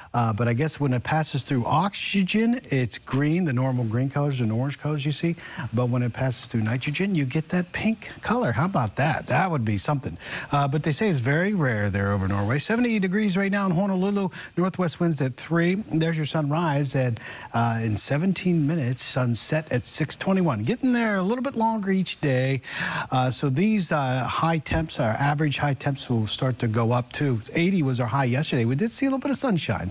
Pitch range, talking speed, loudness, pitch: 125-180 Hz, 210 wpm, -24 LUFS, 145 Hz